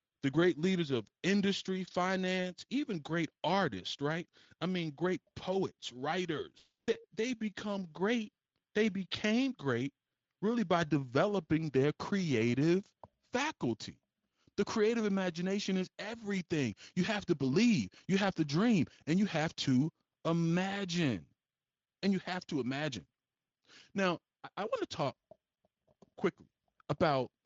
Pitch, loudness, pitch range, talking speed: 180 Hz, -34 LUFS, 155-200 Hz, 130 wpm